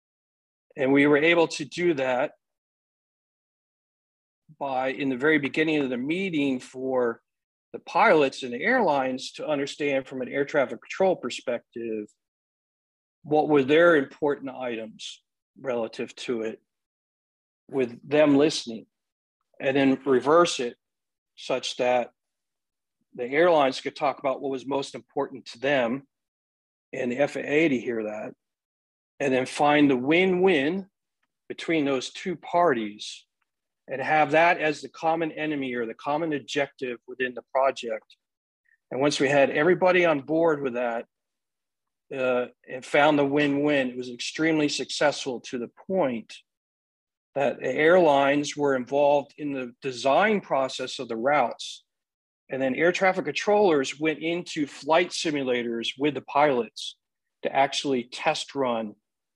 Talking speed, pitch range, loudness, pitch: 135 wpm, 125-155 Hz, -25 LUFS, 140 Hz